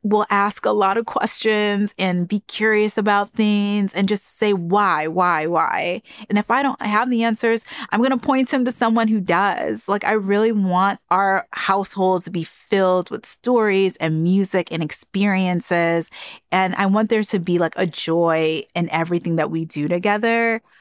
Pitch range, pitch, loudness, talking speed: 180-220 Hz, 200 Hz, -19 LUFS, 180 wpm